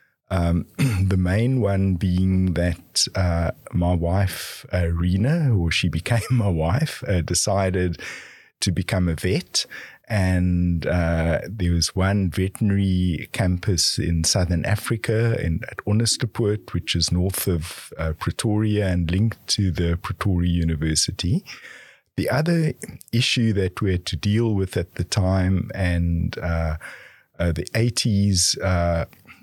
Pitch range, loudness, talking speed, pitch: 85-105 Hz, -22 LUFS, 135 wpm, 95 Hz